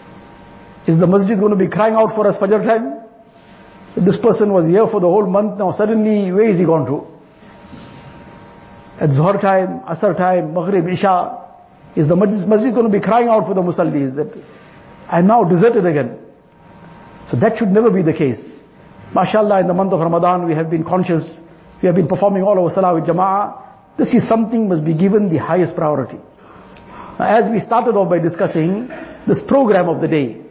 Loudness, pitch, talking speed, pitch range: -15 LUFS, 190 Hz, 195 wpm, 170-215 Hz